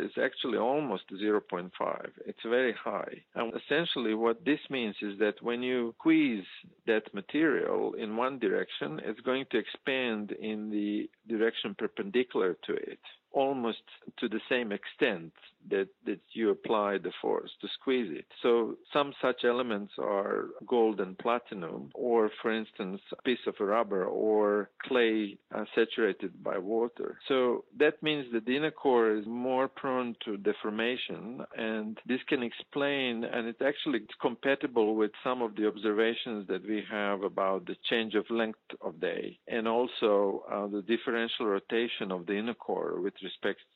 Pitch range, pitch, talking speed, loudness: 110-135 Hz, 115 Hz, 160 wpm, -32 LUFS